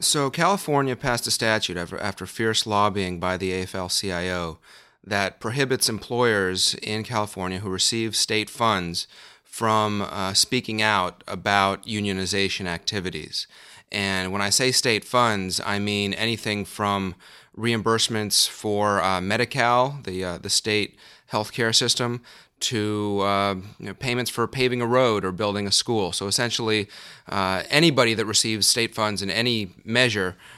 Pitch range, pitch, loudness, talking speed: 95-115 Hz, 105 Hz, -23 LUFS, 145 wpm